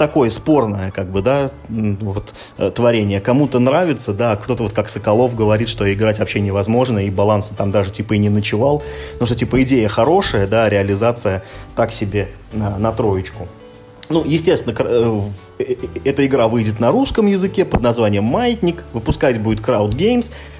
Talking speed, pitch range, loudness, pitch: 155 wpm, 100-130 Hz, -17 LUFS, 110 Hz